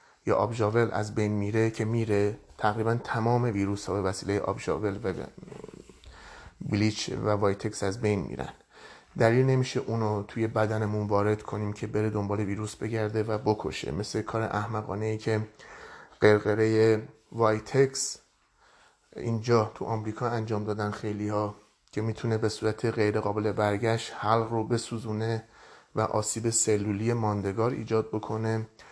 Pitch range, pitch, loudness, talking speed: 105-115 Hz, 110 Hz, -28 LUFS, 135 wpm